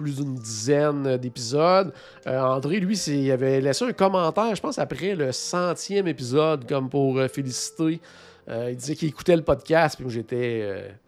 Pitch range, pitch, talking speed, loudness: 130-165 Hz, 145 Hz, 185 wpm, -24 LUFS